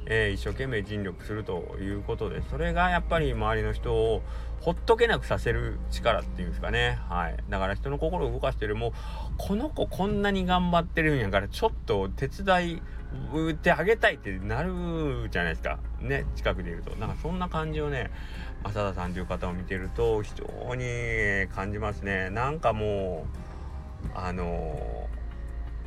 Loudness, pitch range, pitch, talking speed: -29 LUFS, 90-145 Hz, 105 Hz, 350 characters per minute